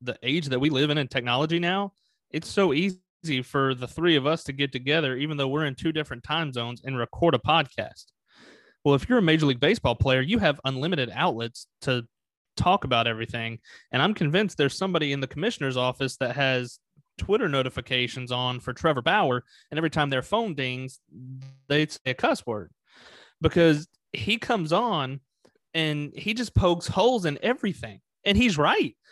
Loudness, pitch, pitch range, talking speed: -25 LUFS, 140 Hz, 130-165 Hz, 185 wpm